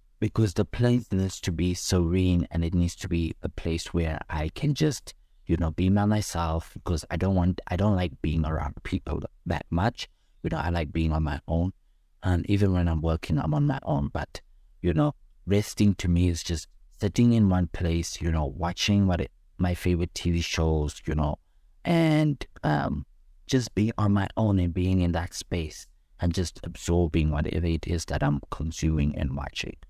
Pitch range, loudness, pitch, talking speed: 80-95 Hz, -27 LUFS, 85 Hz, 195 wpm